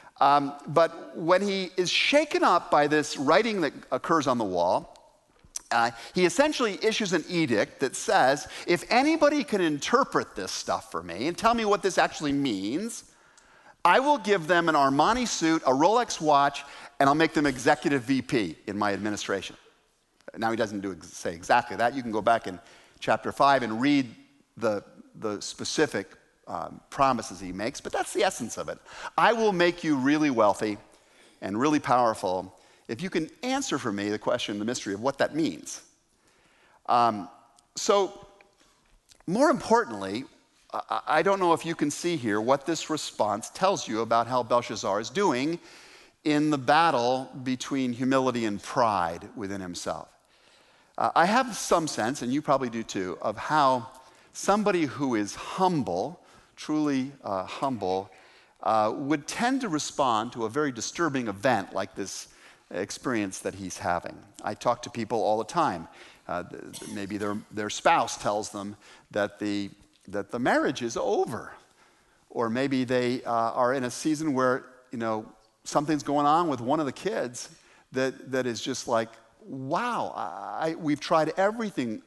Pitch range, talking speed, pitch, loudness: 115-190 Hz, 165 wpm, 145 Hz, -27 LUFS